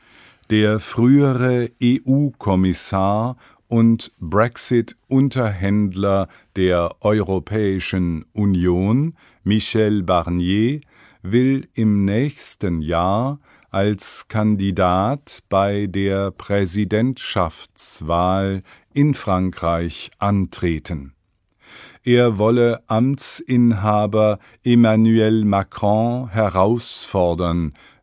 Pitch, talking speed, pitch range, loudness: 105 Hz, 60 wpm, 95-120 Hz, -19 LUFS